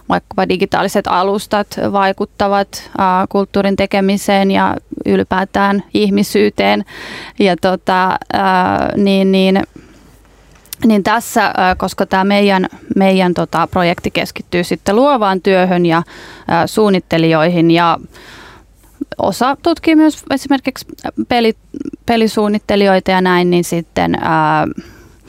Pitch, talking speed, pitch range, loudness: 195 Hz, 100 wpm, 180-210 Hz, -13 LUFS